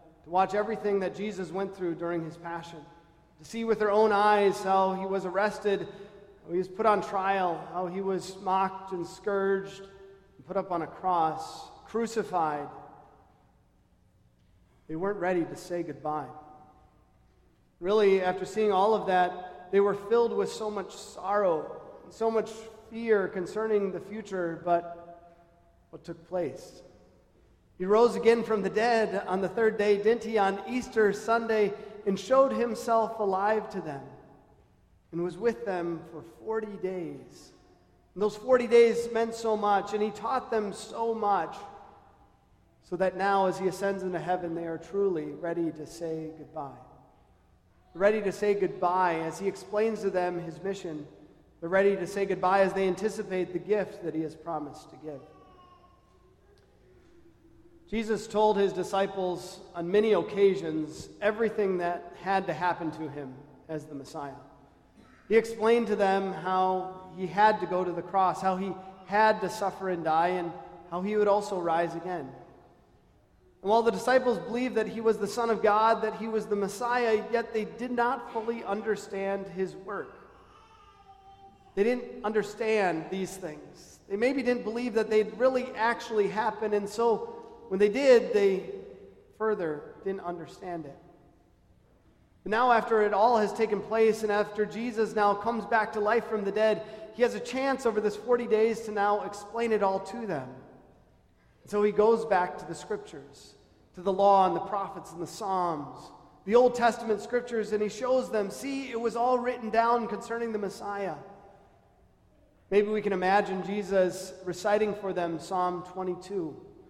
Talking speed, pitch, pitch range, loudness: 165 wpm, 200 Hz, 180-220 Hz, -28 LUFS